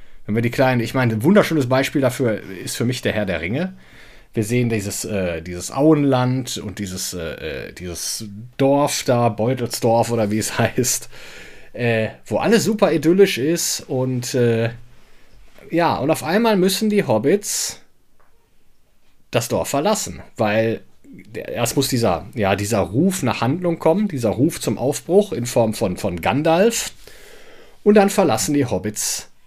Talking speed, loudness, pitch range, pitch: 150 wpm, -19 LUFS, 110-160 Hz, 125 Hz